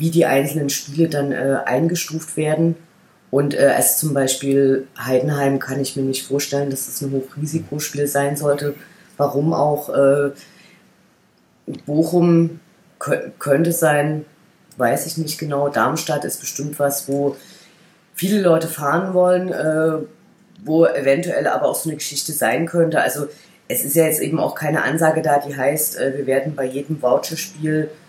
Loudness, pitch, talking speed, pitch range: -19 LUFS, 150 Hz, 155 wpm, 140-165 Hz